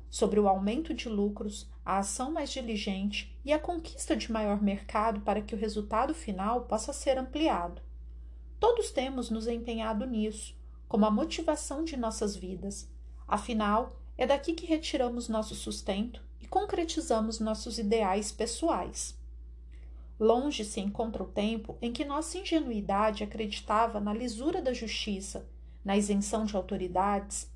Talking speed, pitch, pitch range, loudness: 140 wpm, 220 Hz, 200-255 Hz, -32 LUFS